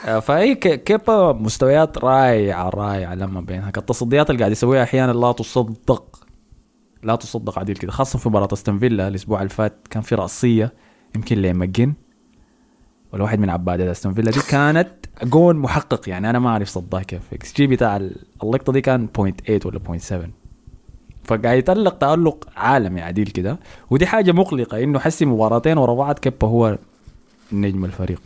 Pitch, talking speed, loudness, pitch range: 115 Hz, 160 wpm, -19 LUFS, 100-130 Hz